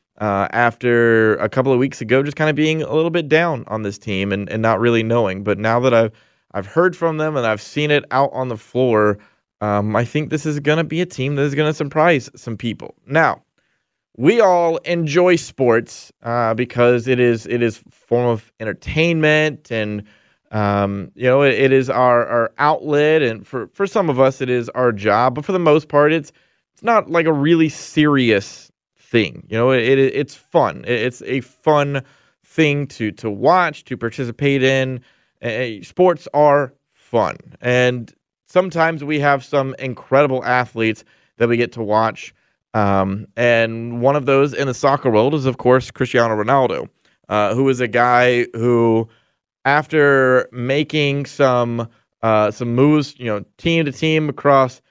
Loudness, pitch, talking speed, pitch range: -17 LUFS, 130 Hz, 185 wpm, 115-145 Hz